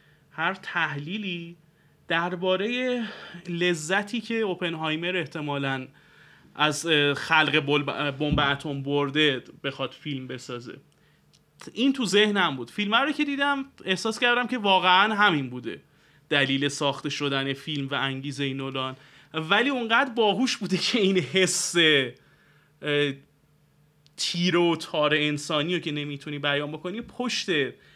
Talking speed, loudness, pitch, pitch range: 115 wpm, -25 LUFS, 155 Hz, 145-190 Hz